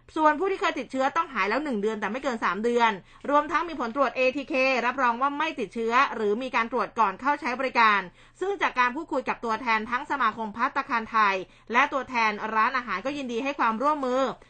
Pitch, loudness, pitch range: 250 Hz, -25 LUFS, 220-275 Hz